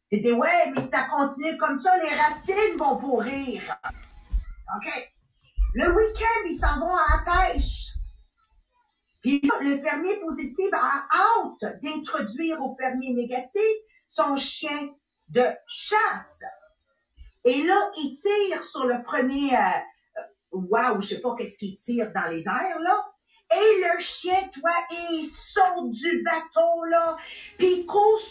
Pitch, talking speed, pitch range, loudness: 320 Hz, 140 wpm, 265-370 Hz, -25 LUFS